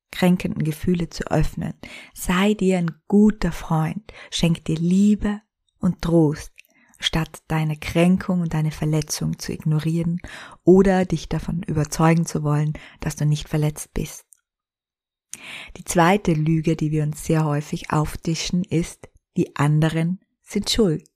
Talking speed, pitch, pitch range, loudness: 135 wpm, 165 Hz, 155-185 Hz, -22 LUFS